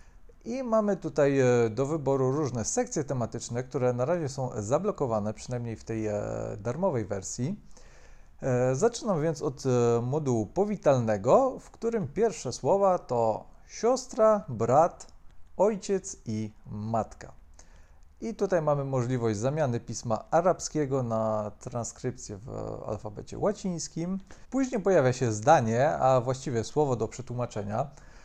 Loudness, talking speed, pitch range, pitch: -28 LUFS, 115 wpm, 115-175 Hz, 130 Hz